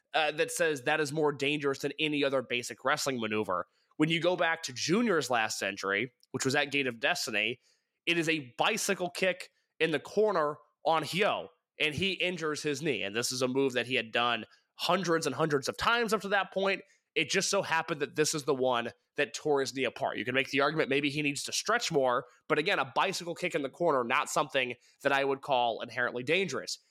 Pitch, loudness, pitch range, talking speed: 145 Hz, -30 LUFS, 130-170 Hz, 225 wpm